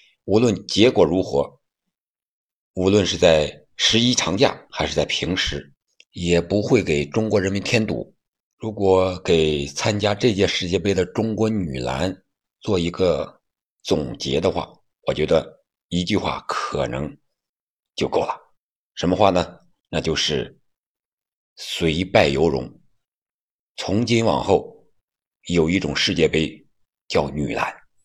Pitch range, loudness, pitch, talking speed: 85-105 Hz, -21 LUFS, 95 Hz, 185 characters per minute